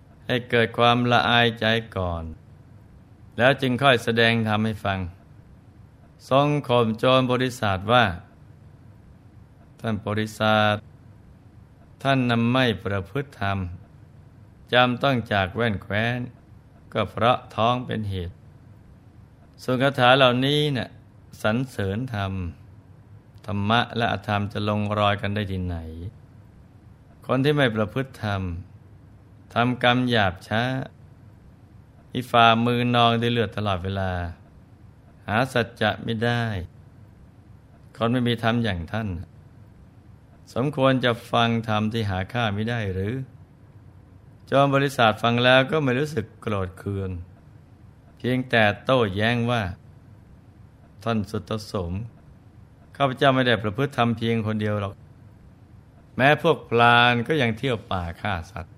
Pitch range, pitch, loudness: 100-125 Hz, 115 Hz, -23 LUFS